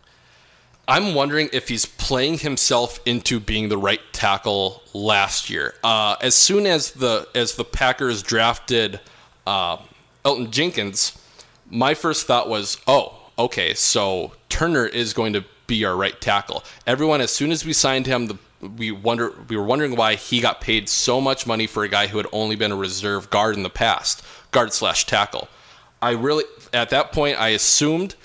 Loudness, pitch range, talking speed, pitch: -20 LUFS, 105-135 Hz, 175 wpm, 115 Hz